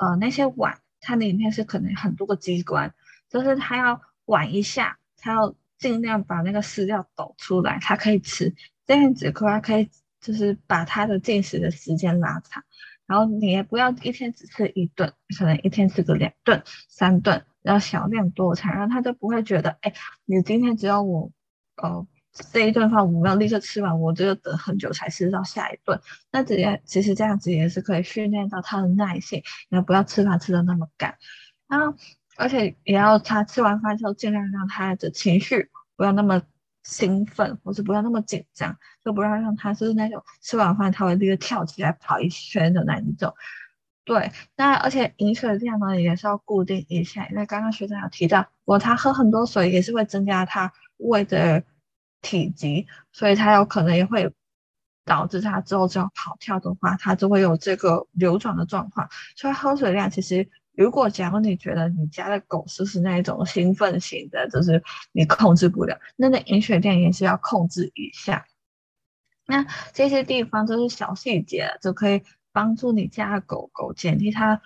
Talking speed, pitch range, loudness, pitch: 285 characters per minute, 180-215 Hz, -22 LUFS, 200 Hz